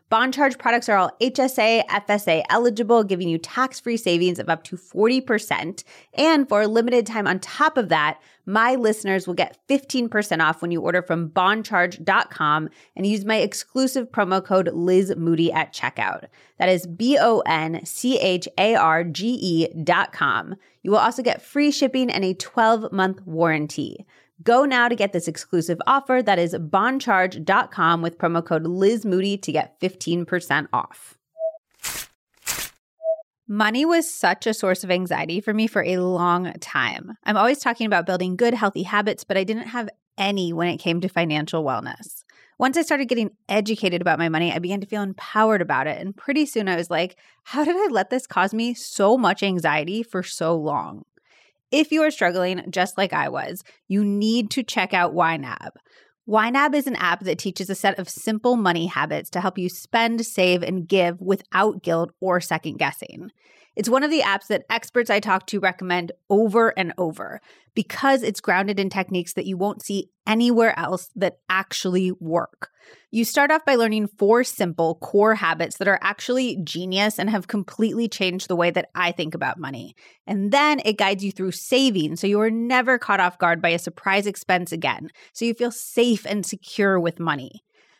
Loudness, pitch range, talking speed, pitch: -21 LUFS, 175-230 Hz, 185 wpm, 195 Hz